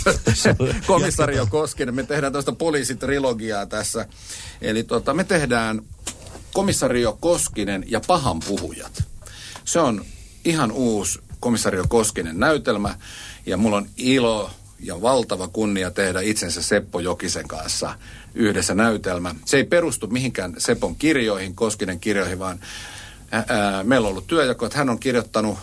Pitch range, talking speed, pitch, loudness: 95-125 Hz, 130 wpm, 110 Hz, -21 LUFS